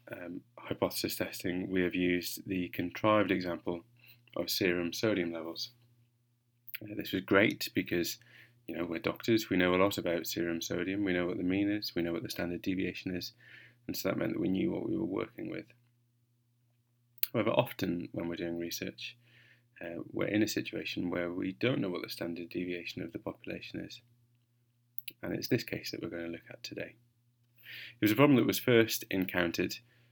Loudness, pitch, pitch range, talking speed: -33 LUFS, 105 Hz, 90-120 Hz, 190 wpm